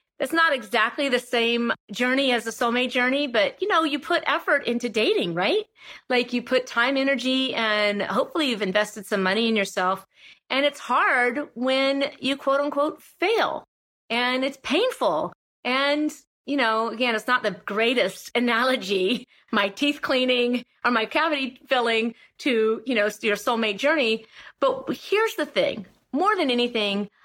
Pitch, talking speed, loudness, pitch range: 250 Hz, 160 wpm, -23 LUFS, 225-285 Hz